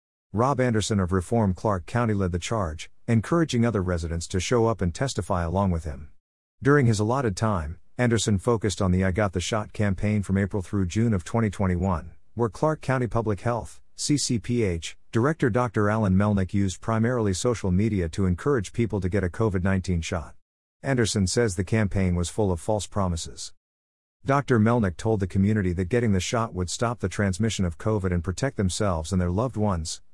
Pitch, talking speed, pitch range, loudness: 105 Hz, 185 wpm, 90-115 Hz, -25 LUFS